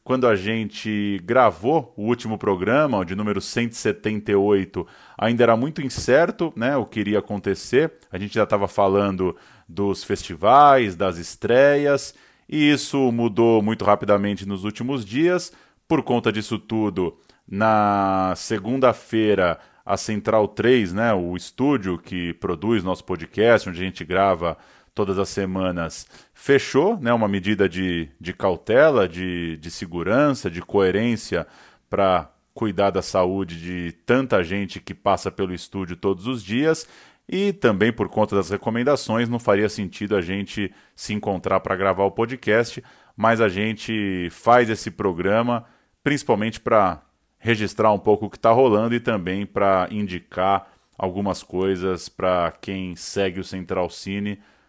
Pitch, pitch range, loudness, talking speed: 105 Hz, 95-115 Hz, -21 LUFS, 140 wpm